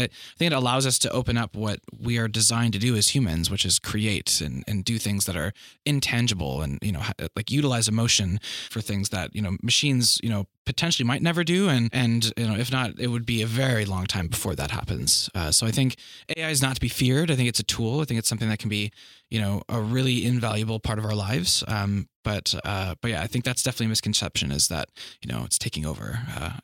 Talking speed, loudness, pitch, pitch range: 250 wpm, -24 LUFS, 110 Hz, 100-125 Hz